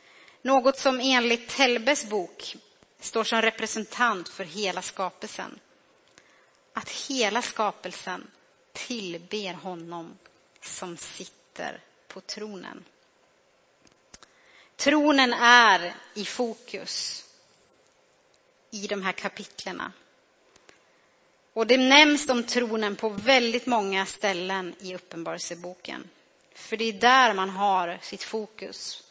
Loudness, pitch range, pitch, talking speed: -24 LUFS, 190-260 Hz, 225 Hz, 95 wpm